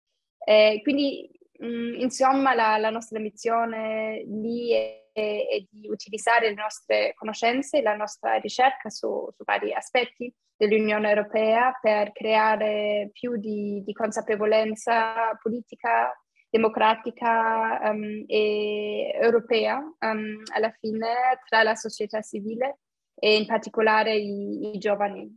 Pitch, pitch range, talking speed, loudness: 220 Hz, 215-235 Hz, 115 wpm, -25 LUFS